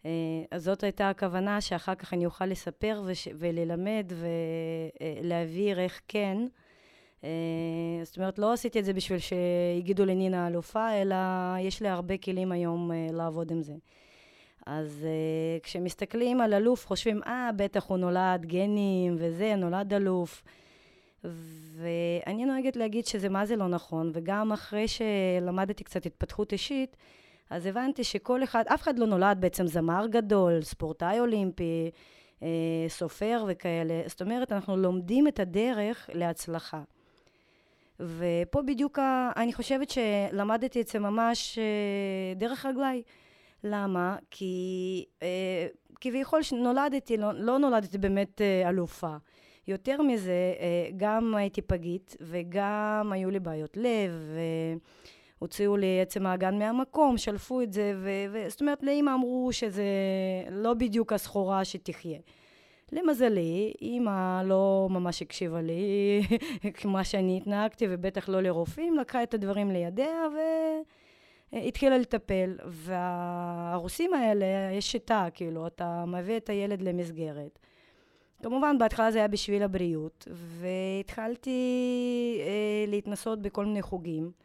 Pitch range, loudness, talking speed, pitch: 175-225 Hz, -30 LUFS, 125 wpm, 195 Hz